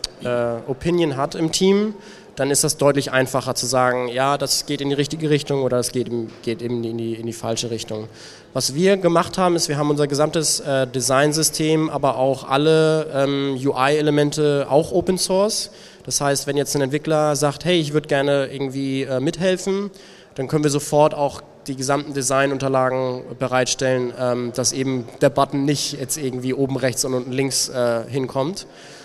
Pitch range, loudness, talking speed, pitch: 130-155 Hz, -20 LUFS, 180 wpm, 140 Hz